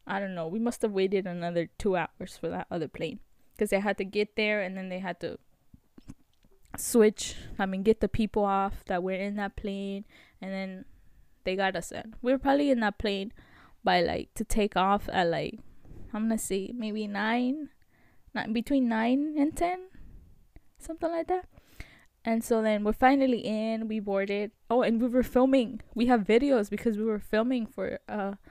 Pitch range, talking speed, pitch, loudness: 195-245 Hz, 190 wpm, 215 Hz, -29 LUFS